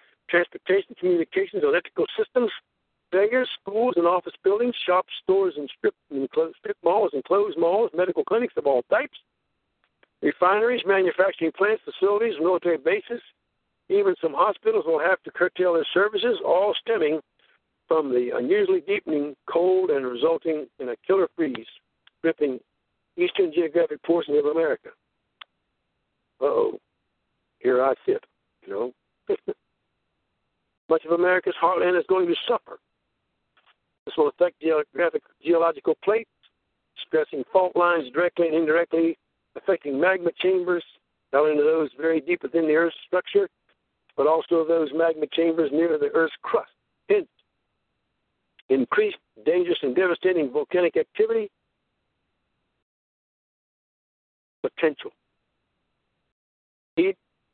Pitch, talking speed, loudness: 190 Hz, 115 wpm, -23 LUFS